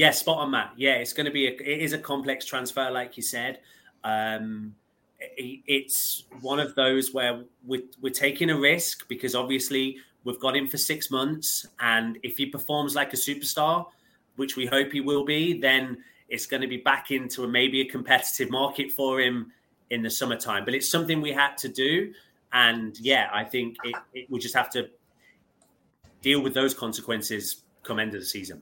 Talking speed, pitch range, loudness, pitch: 195 wpm, 125-140 Hz, -26 LUFS, 130 Hz